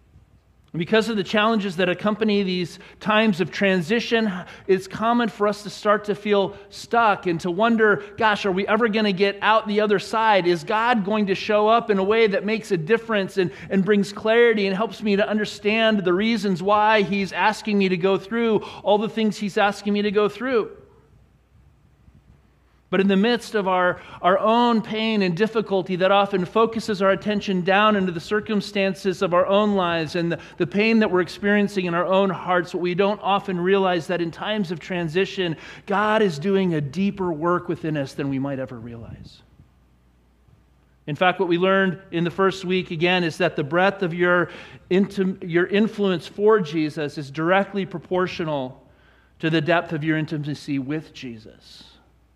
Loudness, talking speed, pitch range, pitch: -21 LUFS, 185 wpm, 175-210 Hz, 195 Hz